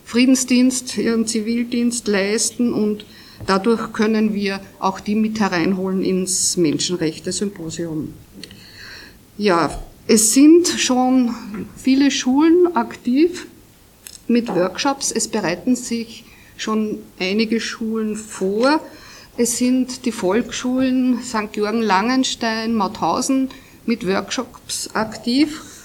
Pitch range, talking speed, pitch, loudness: 205-255 Hz, 95 wpm, 225 Hz, -19 LUFS